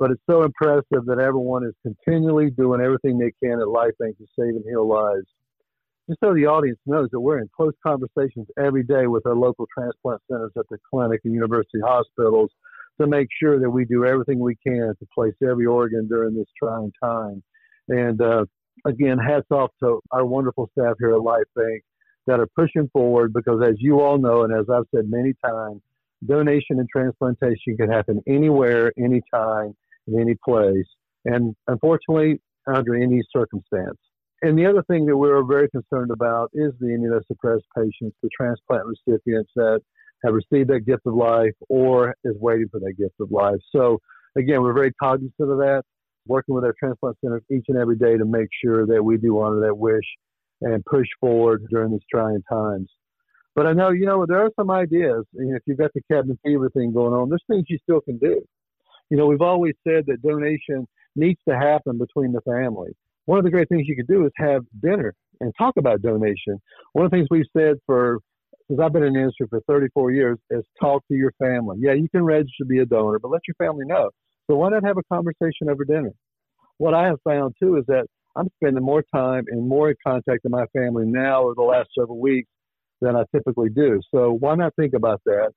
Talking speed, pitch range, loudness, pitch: 210 wpm, 115-150 Hz, -21 LUFS, 130 Hz